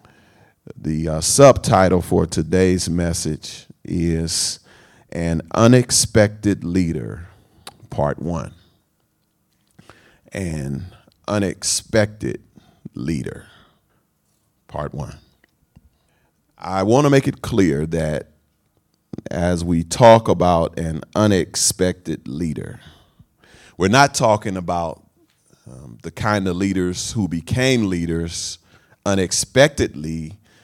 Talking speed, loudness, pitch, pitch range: 85 wpm, -18 LUFS, 95 Hz, 85-110 Hz